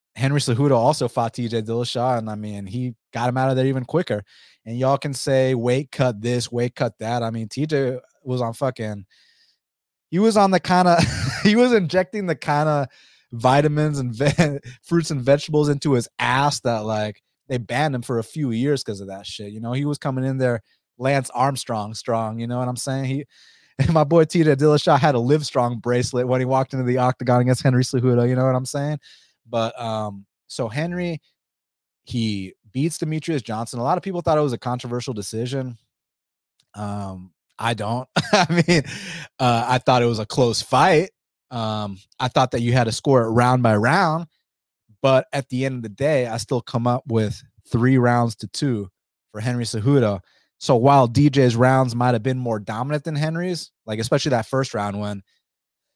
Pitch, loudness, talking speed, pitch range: 125 Hz, -21 LUFS, 195 wpm, 115-145 Hz